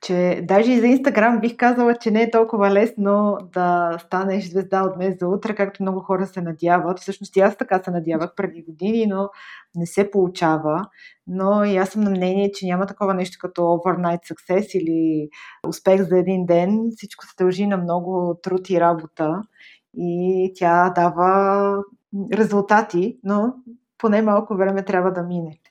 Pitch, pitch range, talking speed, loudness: 190 Hz, 180-205 Hz, 170 wpm, -20 LUFS